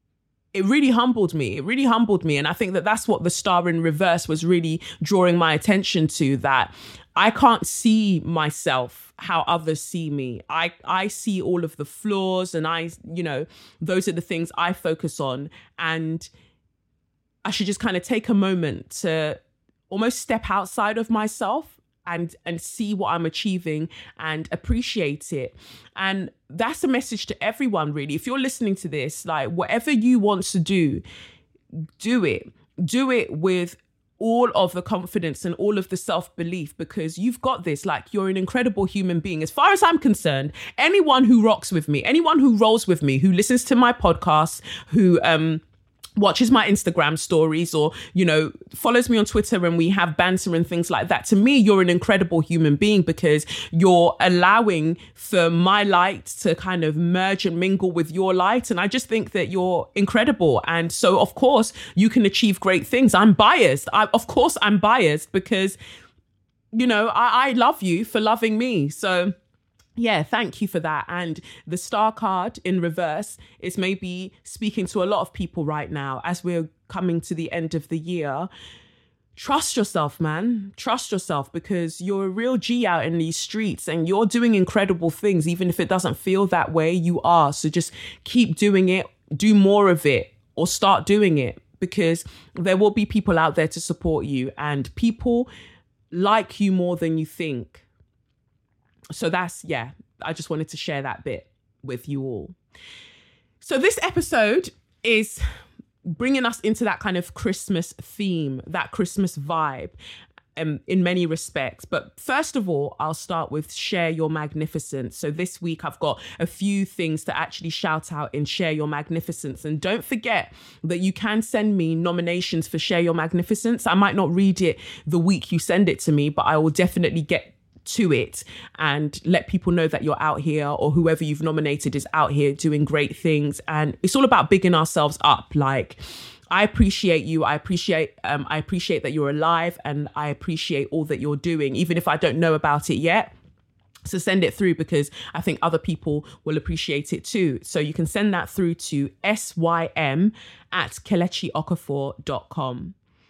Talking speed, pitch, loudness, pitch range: 185 wpm, 175 Hz, -22 LUFS, 155-205 Hz